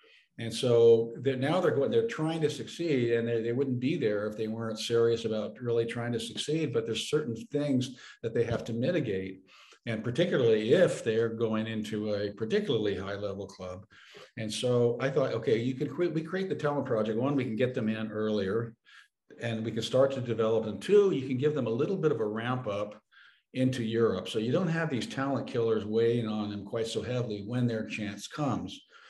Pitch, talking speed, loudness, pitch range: 115 Hz, 210 wpm, -30 LUFS, 110-135 Hz